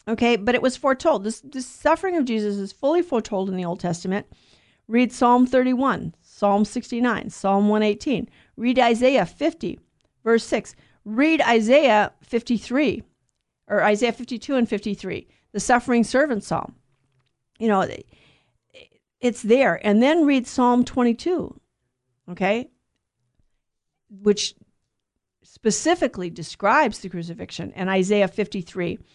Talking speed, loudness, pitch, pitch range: 125 wpm, -21 LUFS, 220 Hz, 190-255 Hz